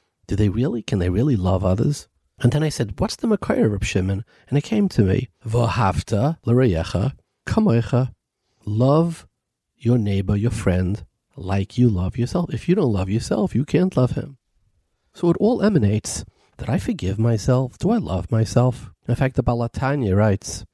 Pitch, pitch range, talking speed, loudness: 115 Hz, 100-130 Hz, 170 wpm, -21 LUFS